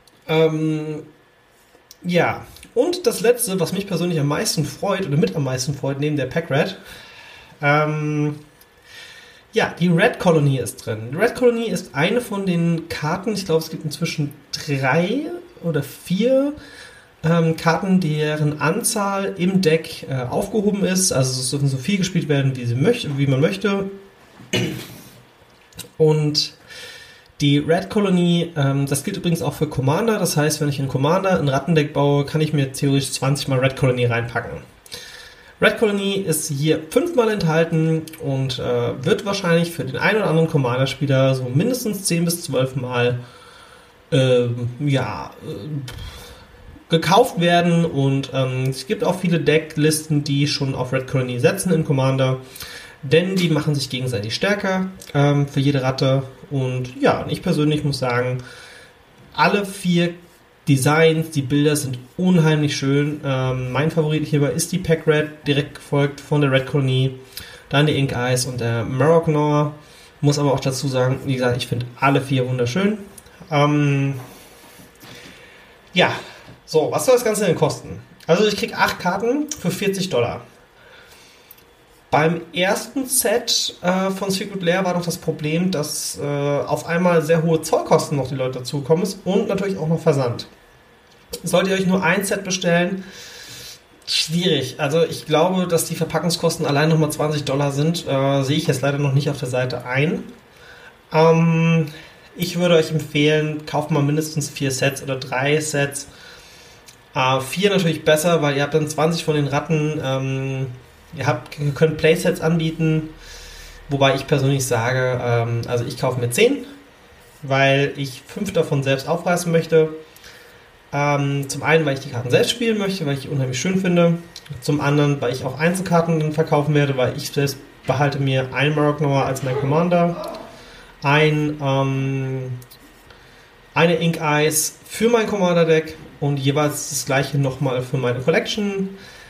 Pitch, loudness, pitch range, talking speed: 150 Hz, -20 LUFS, 135-170 Hz, 160 wpm